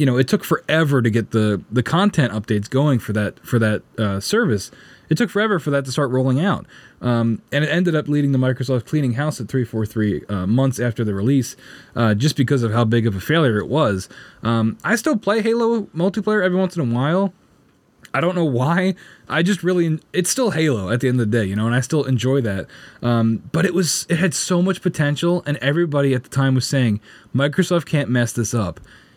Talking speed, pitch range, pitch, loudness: 230 wpm, 115-170 Hz, 135 Hz, -19 LUFS